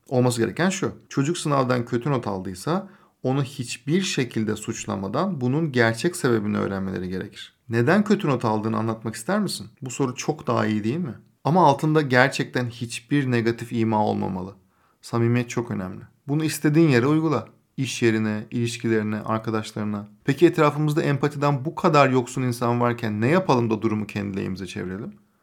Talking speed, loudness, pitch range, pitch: 150 wpm, -23 LUFS, 110-145 Hz, 120 Hz